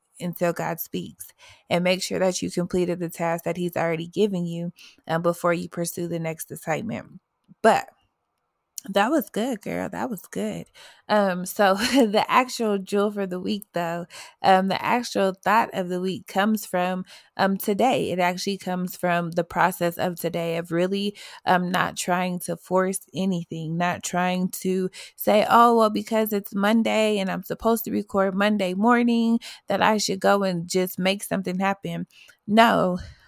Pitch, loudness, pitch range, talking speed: 185 Hz, -24 LUFS, 175-210 Hz, 170 wpm